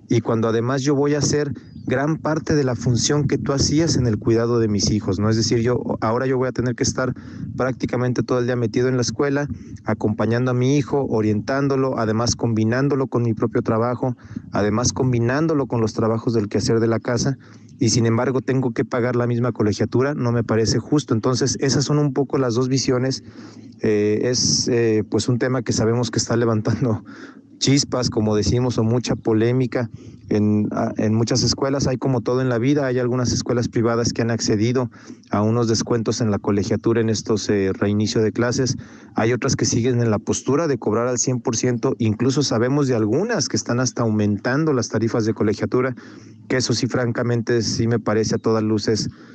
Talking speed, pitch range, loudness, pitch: 195 wpm, 115-130 Hz, -20 LUFS, 120 Hz